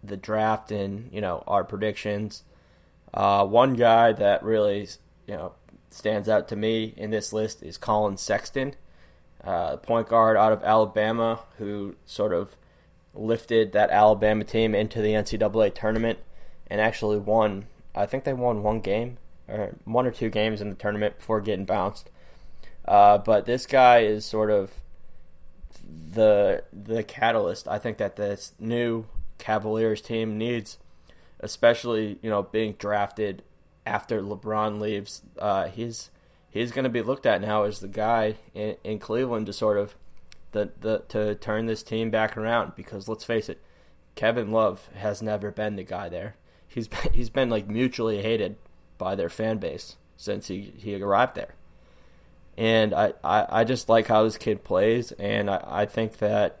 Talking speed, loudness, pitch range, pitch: 165 wpm, -25 LUFS, 100-115 Hz, 110 Hz